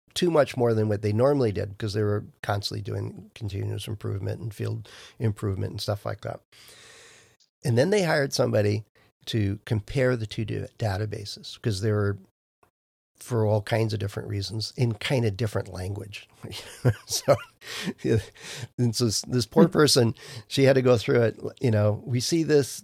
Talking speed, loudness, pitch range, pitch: 170 wpm, -26 LUFS, 105-125 Hz, 110 Hz